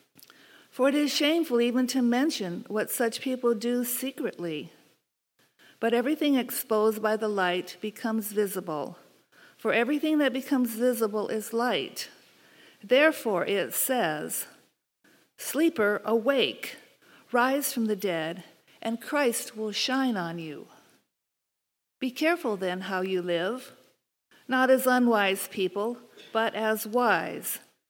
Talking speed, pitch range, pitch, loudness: 120 wpm, 205-260 Hz, 230 Hz, -27 LUFS